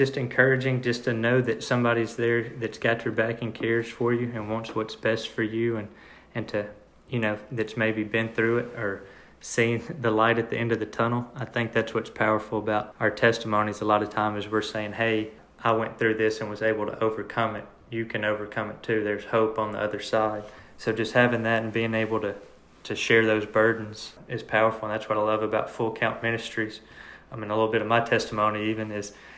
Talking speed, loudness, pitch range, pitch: 230 wpm, -26 LUFS, 110-115 Hz, 110 Hz